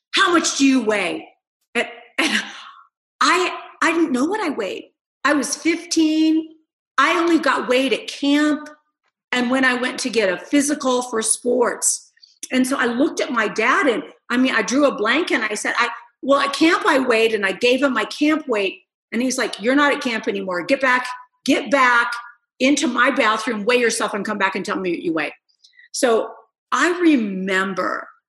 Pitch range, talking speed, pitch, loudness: 235-310 Hz, 195 wpm, 260 Hz, -19 LUFS